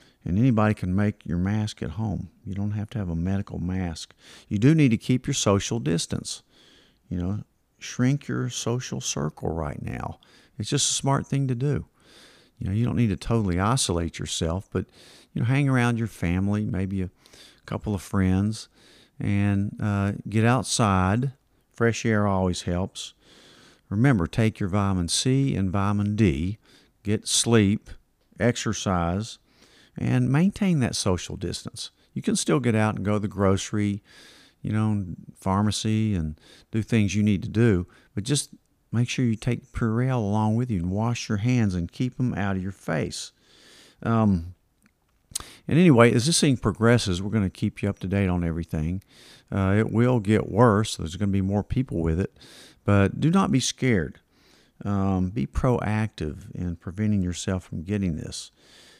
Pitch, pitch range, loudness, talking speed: 105 Hz, 95-120 Hz, -25 LUFS, 170 wpm